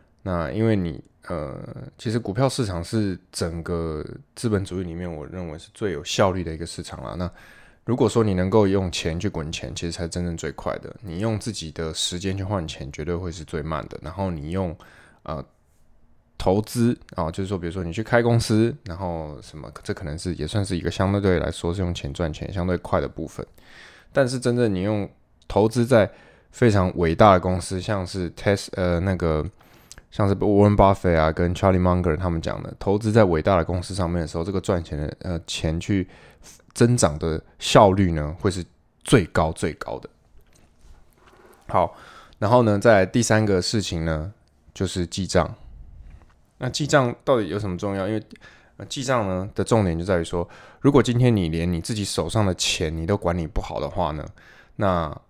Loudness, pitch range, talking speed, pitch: -23 LUFS, 85-105 Hz, 280 characters per minute, 90 Hz